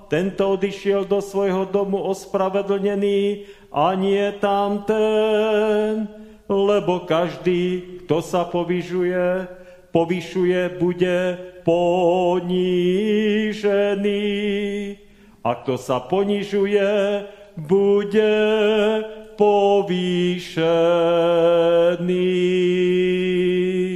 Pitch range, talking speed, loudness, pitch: 180-205 Hz, 60 wpm, -20 LUFS, 195 Hz